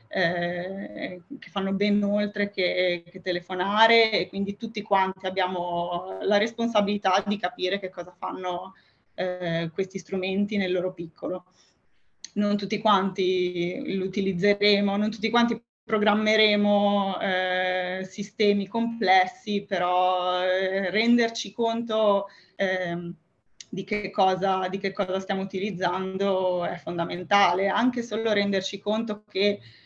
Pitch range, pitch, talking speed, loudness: 185-205 Hz, 195 Hz, 115 wpm, -25 LUFS